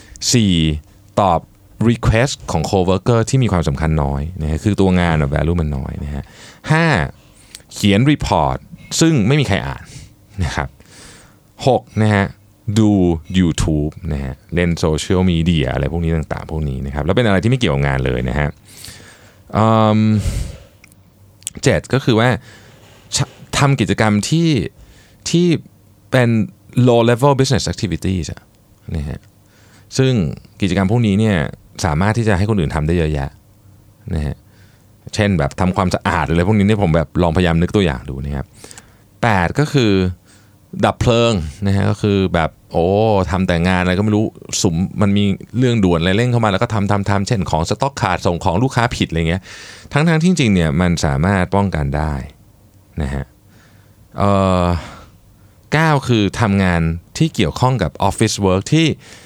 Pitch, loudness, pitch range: 100 Hz, -16 LUFS, 85-110 Hz